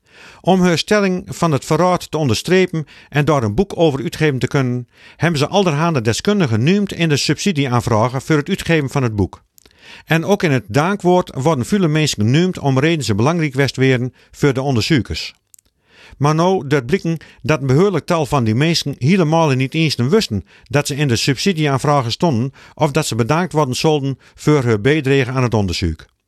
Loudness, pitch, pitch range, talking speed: -16 LUFS, 150 Hz, 130-170 Hz, 185 wpm